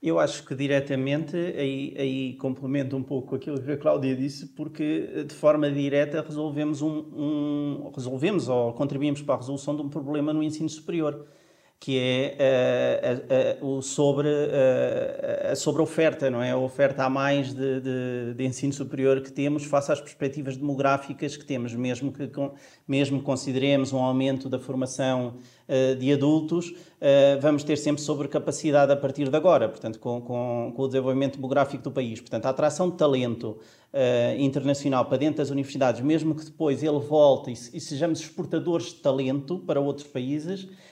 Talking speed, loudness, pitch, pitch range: 175 wpm, -26 LUFS, 140 Hz, 130-150 Hz